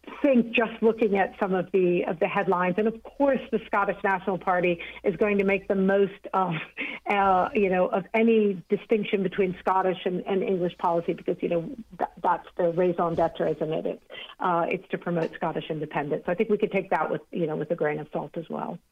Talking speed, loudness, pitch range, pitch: 220 wpm, -26 LUFS, 180-215 Hz, 195 Hz